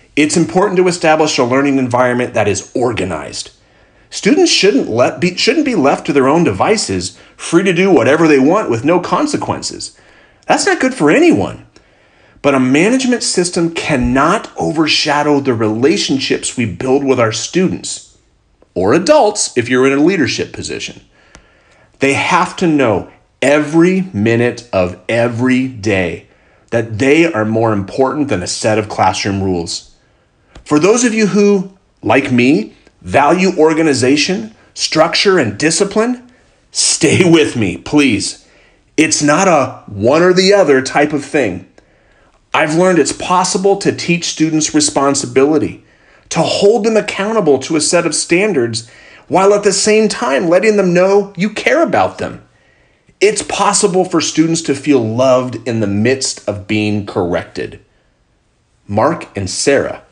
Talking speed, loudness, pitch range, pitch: 145 wpm, -13 LUFS, 120-185 Hz, 150 Hz